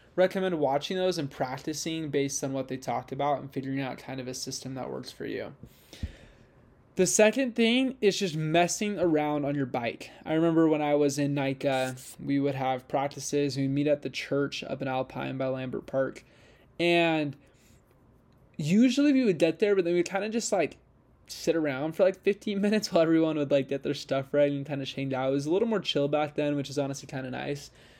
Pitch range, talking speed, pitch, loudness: 135-170 Hz, 215 wpm, 145 Hz, -28 LUFS